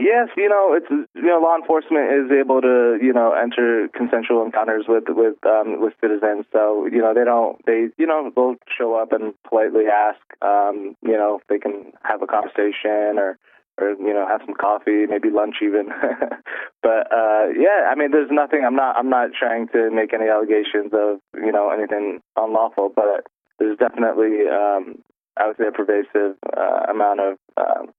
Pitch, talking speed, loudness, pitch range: 110 Hz, 190 wpm, -19 LUFS, 105-120 Hz